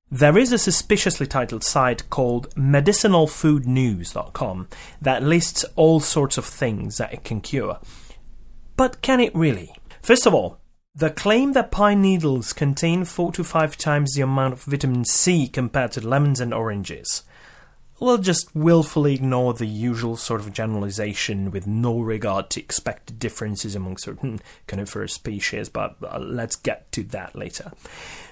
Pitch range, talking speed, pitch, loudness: 115-165 Hz, 150 wpm, 135 Hz, -21 LUFS